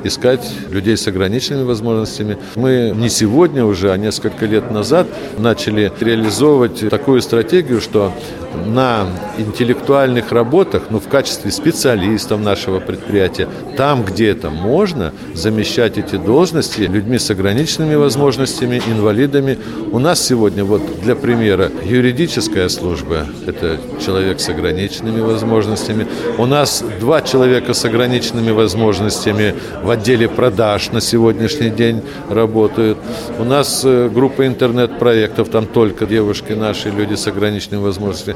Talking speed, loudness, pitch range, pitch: 120 wpm, -15 LUFS, 105-125 Hz, 110 Hz